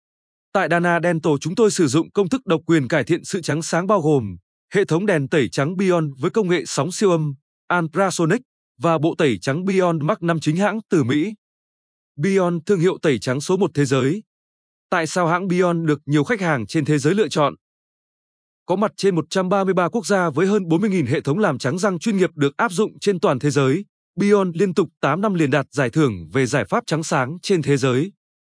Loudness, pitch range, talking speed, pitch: -20 LUFS, 150-195 Hz, 220 wpm, 170 Hz